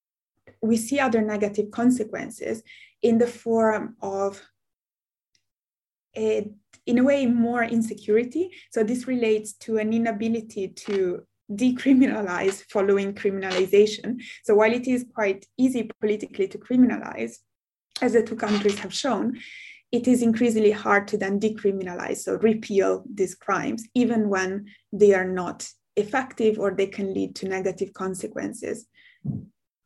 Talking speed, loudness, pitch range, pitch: 130 wpm, -24 LUFS, 195-235 Hz, 215 Hz